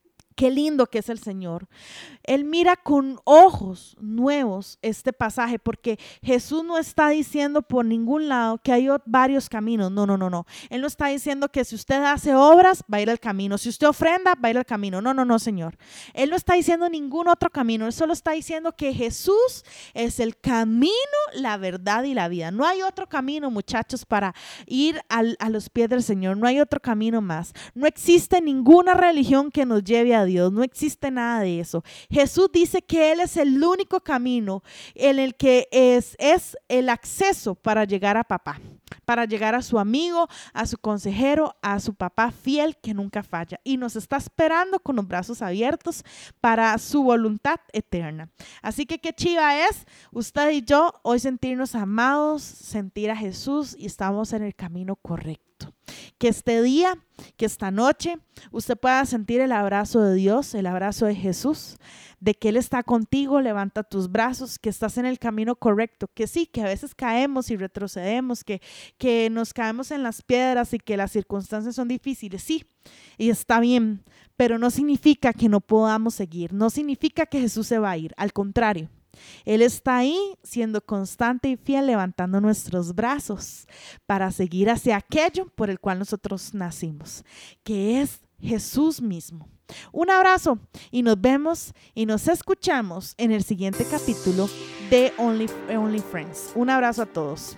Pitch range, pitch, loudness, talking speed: 210-285 Hz, 235 Hz, -22 LUFS, 180 wpm